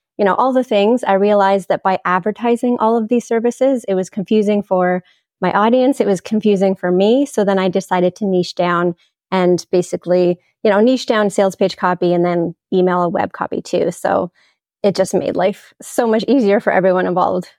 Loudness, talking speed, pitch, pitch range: -16 LUFS, 200 wpm, 195 Hz, 180-220 Hz